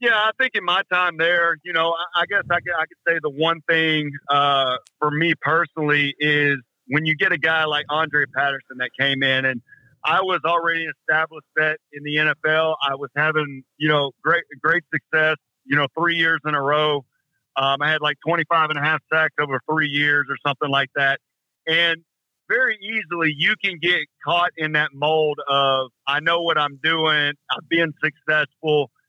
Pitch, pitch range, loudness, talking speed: 155 Hz, 145-165 Hz, -20 LUFS, 195 wpm